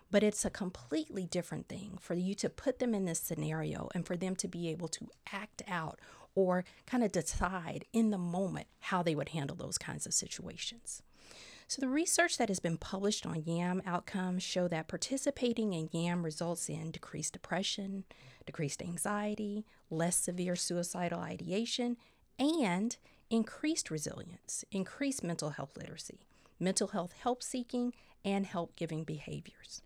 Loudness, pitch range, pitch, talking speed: -36 LUFS, 170-215 Hz, 185 Hz, 155 wpm